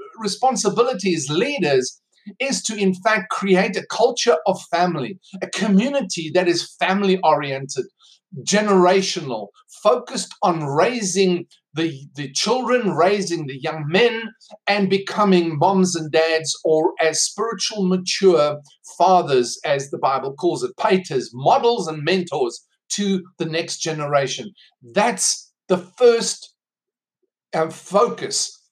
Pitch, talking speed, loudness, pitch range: 185 Hz, 115 wpm, -20 LUFS, 165-220 Hz